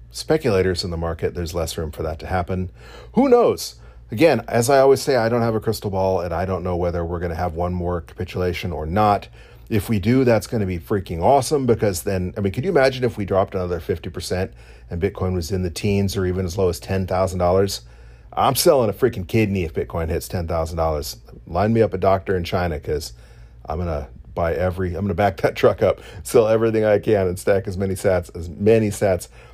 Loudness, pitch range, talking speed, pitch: -21 LUFS, 85-105 Hz, 230 wpm, 95 Hz